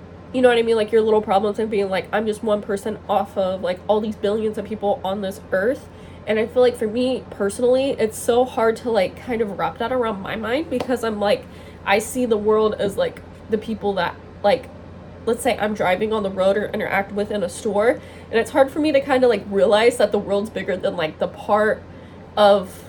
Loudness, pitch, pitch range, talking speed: -21 LUFS, 220 Hz, 205-240 Hz, 240 wpm